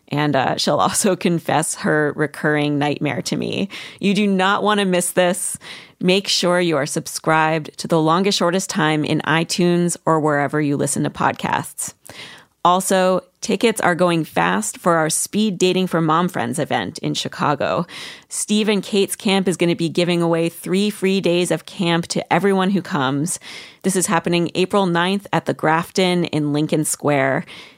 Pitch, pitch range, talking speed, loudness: 175 Hz, 155-190 Hz, 170 wpm, -19 LUFS